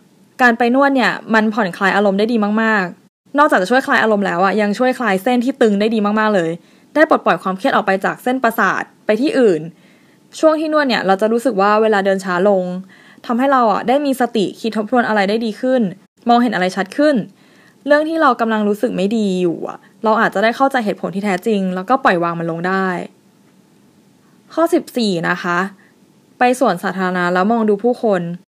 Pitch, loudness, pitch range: 215 Hz, -16 LUFS, 190-250 Hz